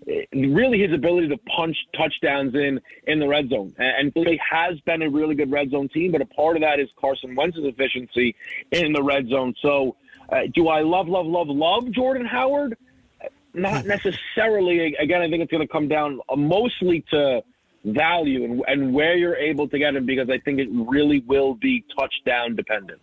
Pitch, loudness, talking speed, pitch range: 155 Hz, -21 LUFS, 195 wpm, 140-175 Hz